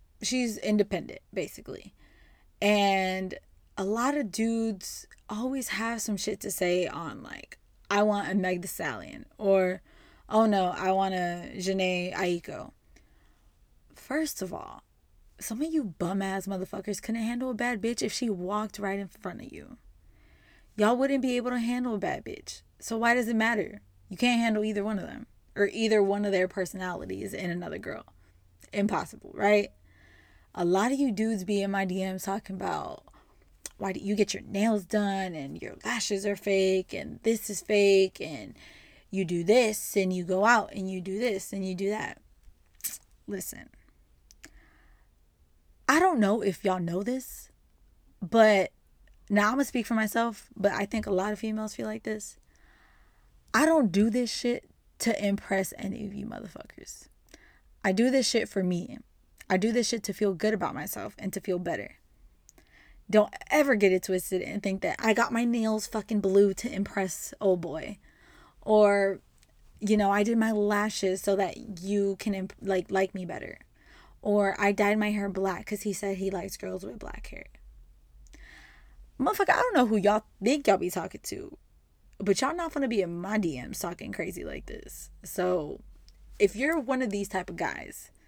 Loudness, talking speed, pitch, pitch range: -28 LUFS, 180 wpm, 200 Hz, 190-220 Hz